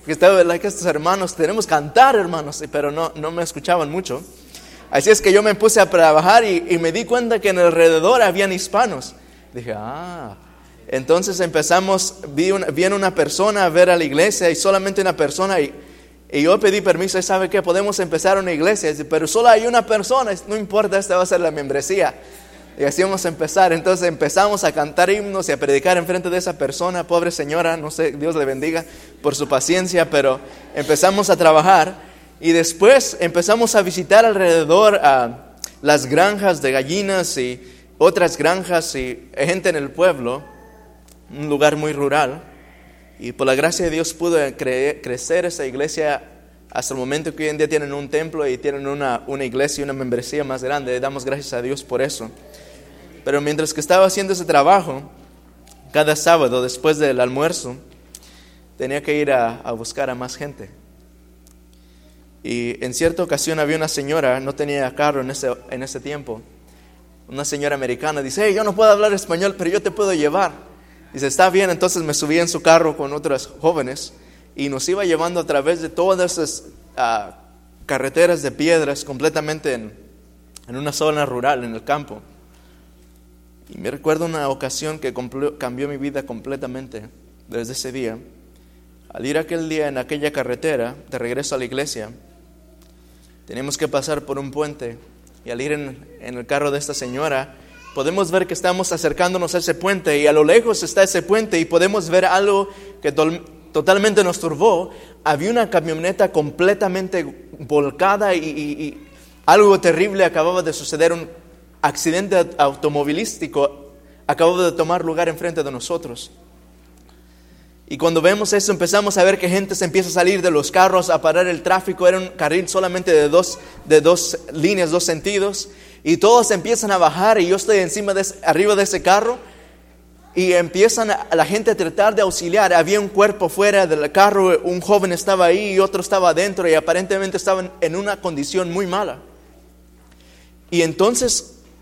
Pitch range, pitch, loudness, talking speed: 135-185 Hz, 160 Hz, -17 LUFS, 180 wpm